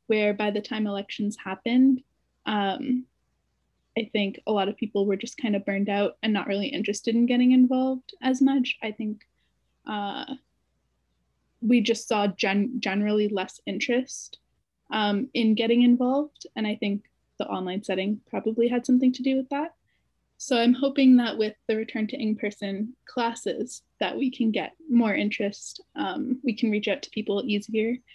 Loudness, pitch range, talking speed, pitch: -26 LUFS, 205-250 Hz, 170 wpm, 220 Hz